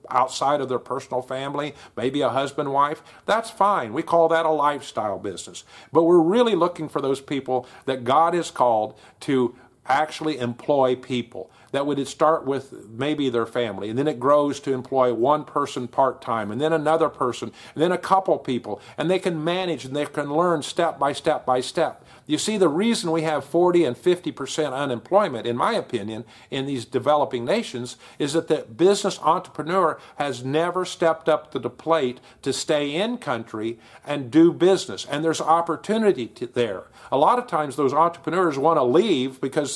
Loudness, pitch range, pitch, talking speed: -23 LUFS, 130-165 Hz, 145 Hz, 185 wpm